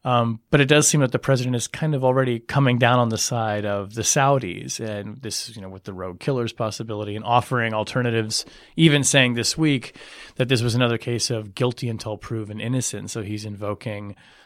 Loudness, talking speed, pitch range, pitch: -22 LUFS, 210 wpm, 105-130 Hz, 115 Hz